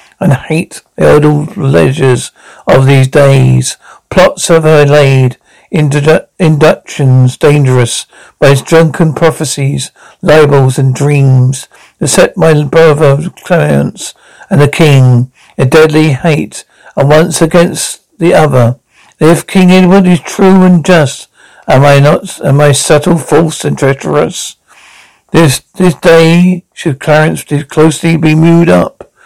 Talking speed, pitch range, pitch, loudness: 130 wpm, 140-165 Hz, 155 Hz, -7 LUFS